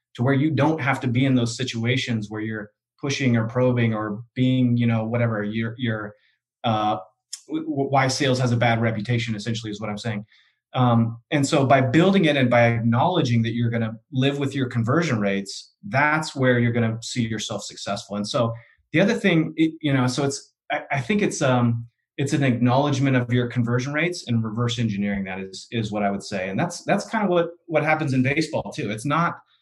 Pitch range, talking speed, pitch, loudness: 115-140 Hz, 215 wpm, 125 Hz, -22 LUFS